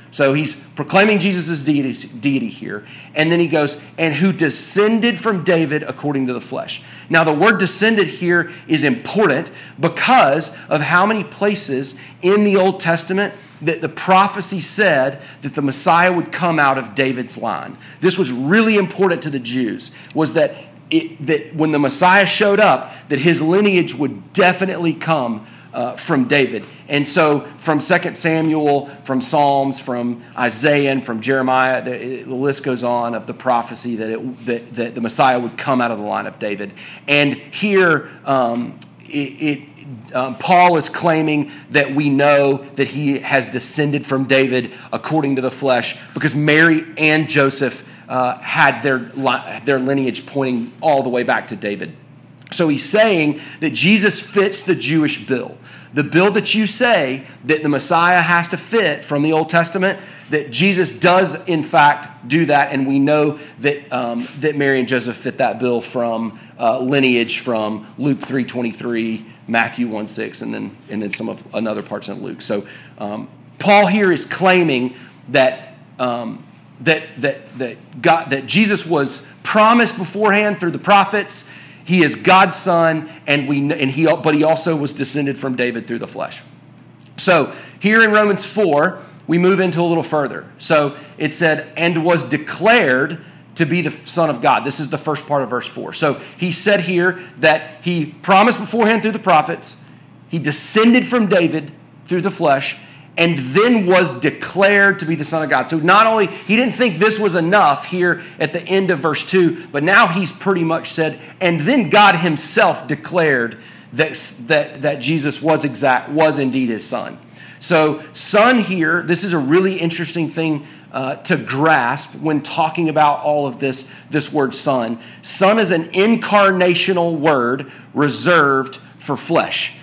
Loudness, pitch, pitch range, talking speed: -16 LUFS, 155 Hz, 135-175 Hz, 170 wpm